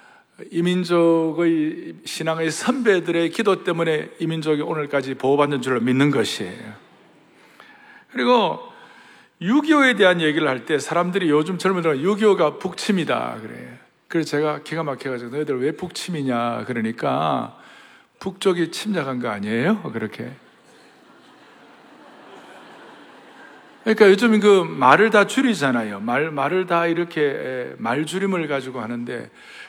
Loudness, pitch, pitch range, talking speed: -20 LUFS, 165 Hz, 140-195 Hz, 275 characters per minute